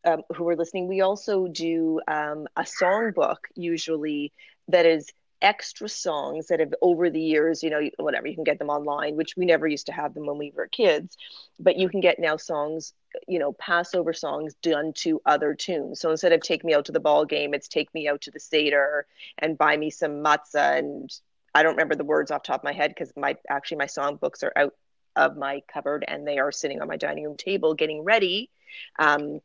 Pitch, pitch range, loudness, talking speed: 155 Hz, 145-175 Hz, -25 LUFS, 220 wpm